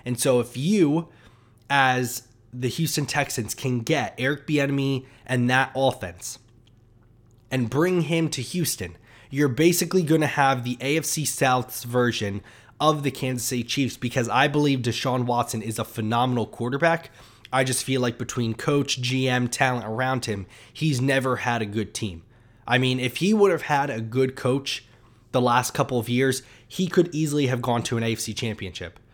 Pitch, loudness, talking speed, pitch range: 125 Hz, -24 LUFS, 170 wpm, 115-140 Hz